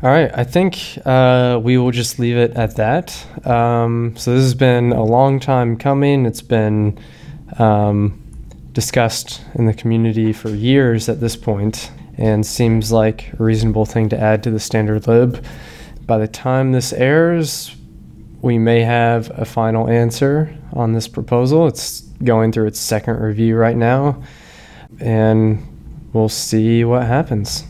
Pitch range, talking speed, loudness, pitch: 110-130 Hz, 155 wpm, -16 LUFS, 115 Hz